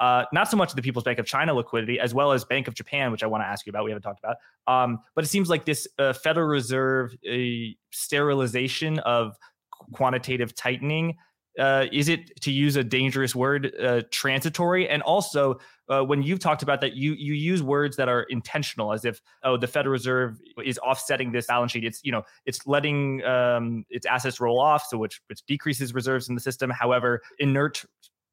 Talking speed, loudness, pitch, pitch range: 210 wpm, -25 LUFS, 130 Hz, 125-145 Hz